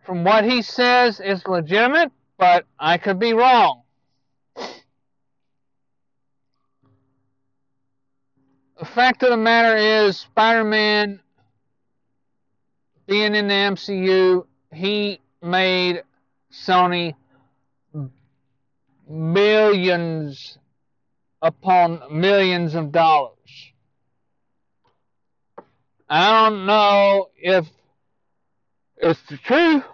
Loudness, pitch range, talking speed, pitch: -17 LUFS, 135-210 Hz, 75 wpm, 180 Hz